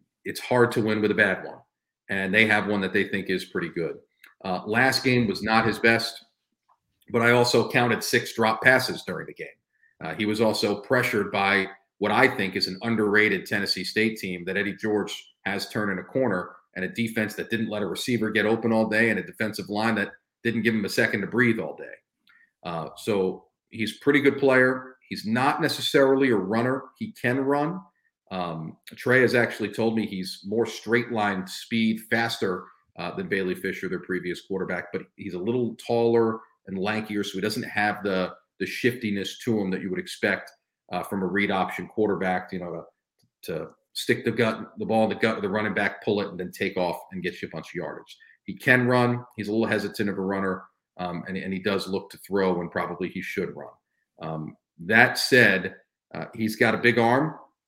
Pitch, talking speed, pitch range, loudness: 110 Hz, 210 wpm, 95-115 Hz, -25 LUFS